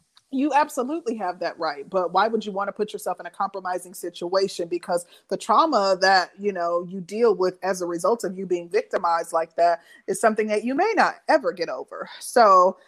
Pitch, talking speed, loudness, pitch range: 195 Hz, 210 wpm, -23 LUFS, 175-225 Hz